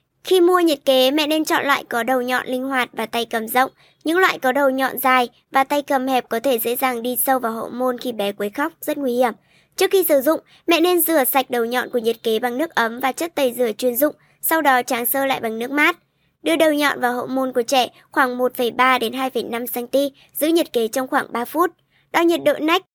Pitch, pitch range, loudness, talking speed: 260 Hz, 245-300 Hz, -19 LUFS, 245 wpm